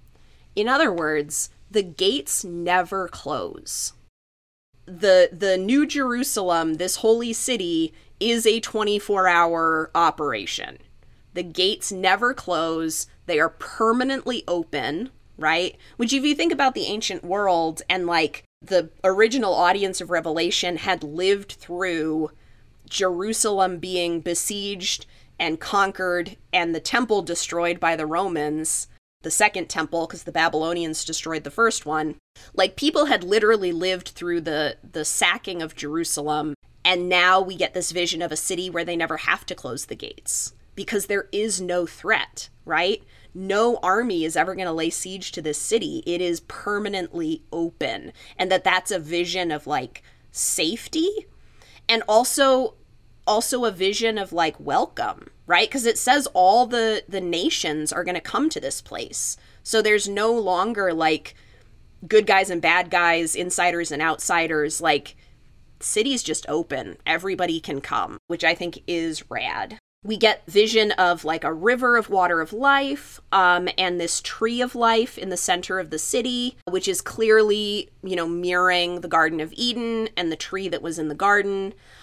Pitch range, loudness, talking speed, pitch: 165-220 Hz, -22 LUFS, 155 wpm, 185 Hz